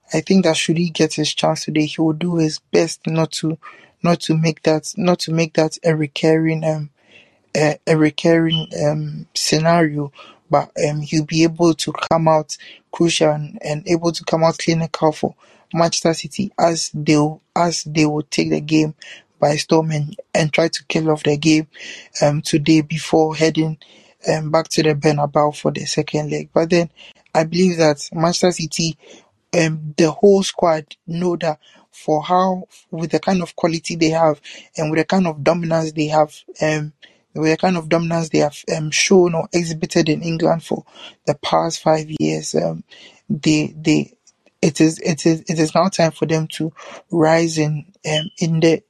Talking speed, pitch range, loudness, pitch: 185 wpm, 155-170 Hz, -18 LUFS, 160 Hz